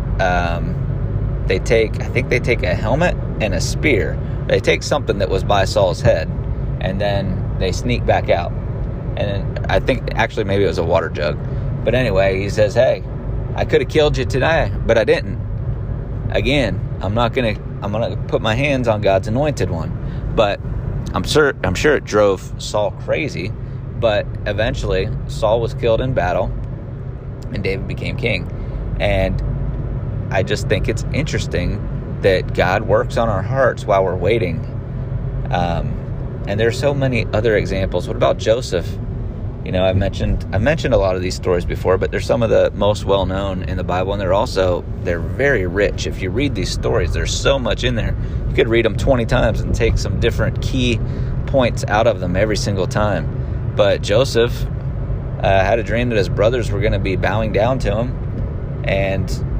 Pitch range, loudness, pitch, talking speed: 100-125 Hz, -18 LUFS, 115 Hz, 185 wpm